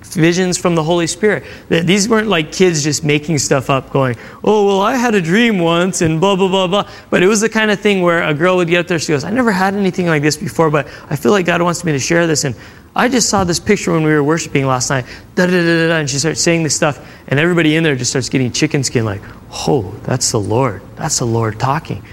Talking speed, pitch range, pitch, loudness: 260 wpm, 145-185 Hz, 165 Hz, -14 LUFS